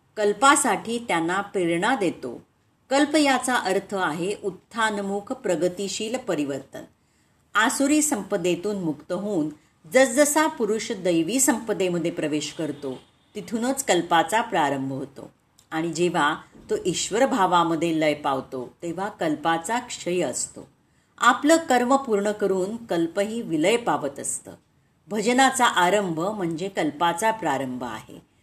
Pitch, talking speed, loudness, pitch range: 200 Hz, 105 wpm, -23 LUFS, 170-240 Hz